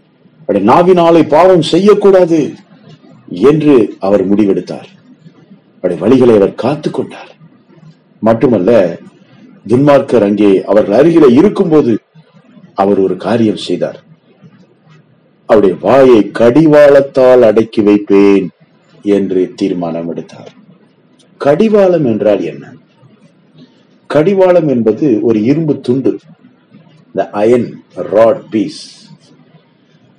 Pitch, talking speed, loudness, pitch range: 125 Hz, 70 wpm, -9 LUFS, 100-165 Hz